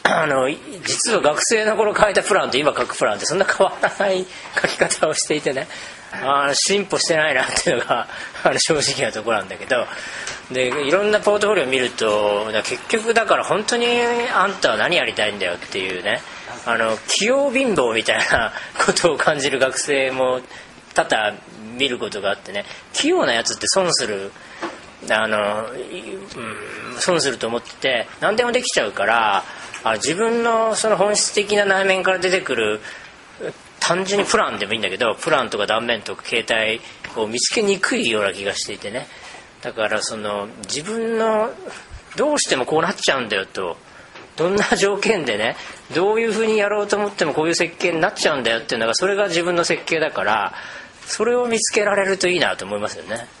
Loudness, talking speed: -19 LUFS, 365 characters per minute